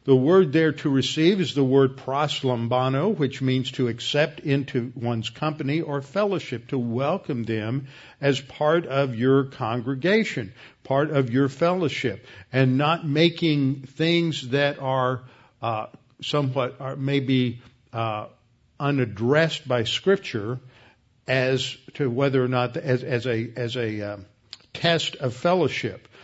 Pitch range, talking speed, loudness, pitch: 125-145 Hz, 135 wpm, -24 LUFS, 135 Hz